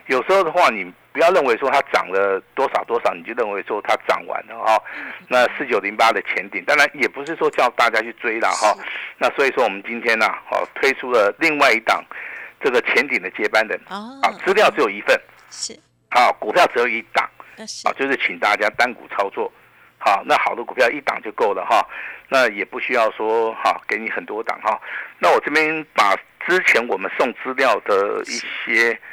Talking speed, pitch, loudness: 295 characters per minute, 195 Hz, -19 LUFS